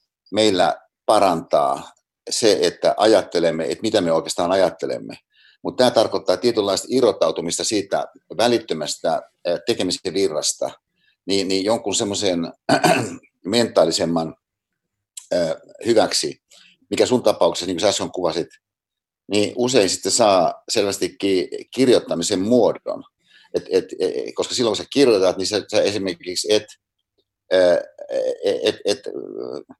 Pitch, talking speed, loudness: 325 Hz, 115 wpm, -20 LUFS